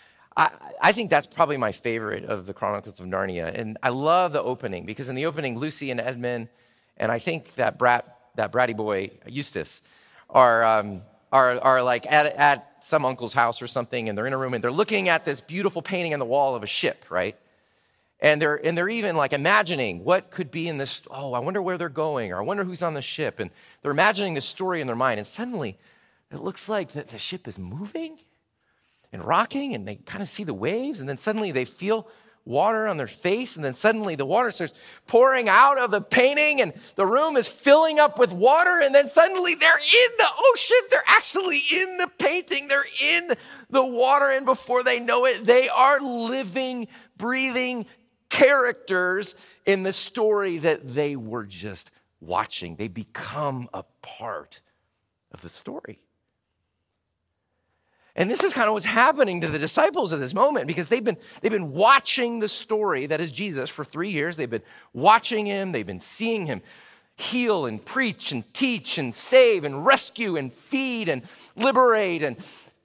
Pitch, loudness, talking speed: 185 Hz, -22 LUFS, 195 wpm